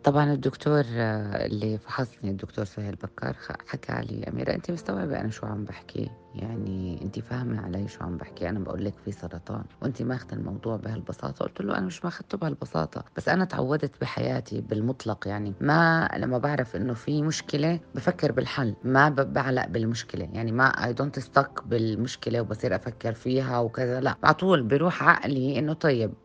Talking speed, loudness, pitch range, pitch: 165 wpm, -28 LUFS, 105-140 Hz, 120 Hz